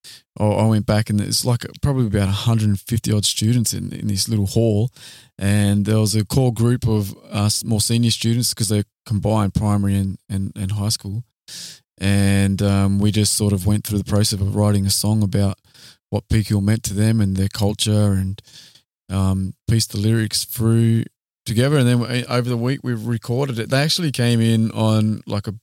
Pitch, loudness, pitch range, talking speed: 110 Hz, -19 LUFS, 100-115 Hz, 190 wpm